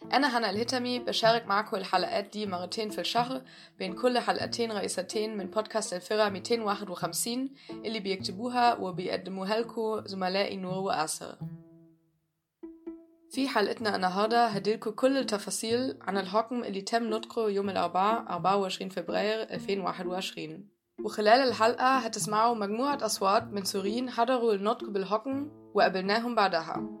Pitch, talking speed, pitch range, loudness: 215 Hz, 120 wpm, 190-235 Hz, -29 LUFS